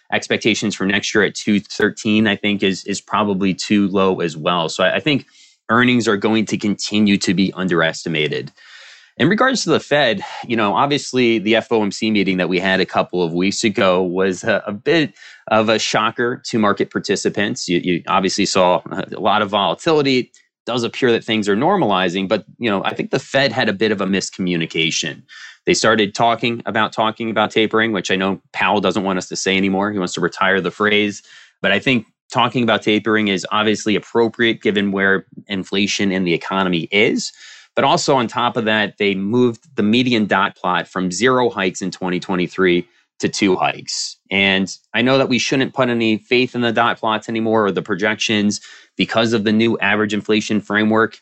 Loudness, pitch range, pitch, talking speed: -17 LUFS, 95-115 Hz, 105 Hz, 195 wpm